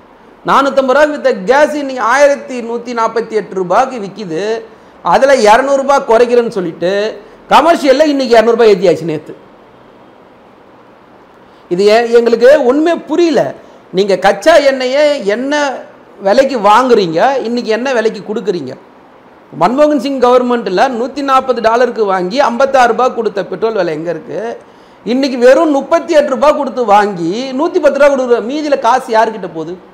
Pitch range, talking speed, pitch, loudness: 215-275 Hz, 125 wpm, 245 Hz, -11 LUFS